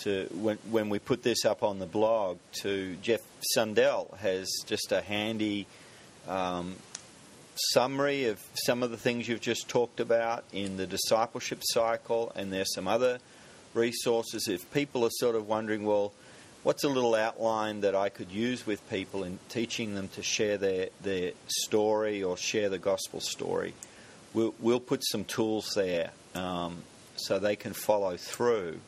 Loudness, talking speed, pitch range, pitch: -31 LUFS, 160 wpm, 95-115 Hz, 110 Hz